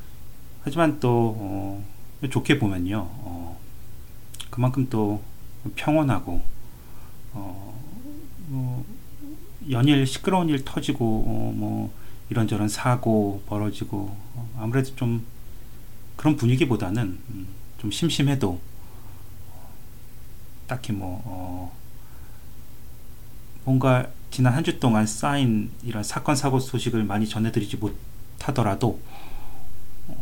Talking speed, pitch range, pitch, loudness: 195 characters per minute, 100-130 Hz, 115 Hz, -25 LUFS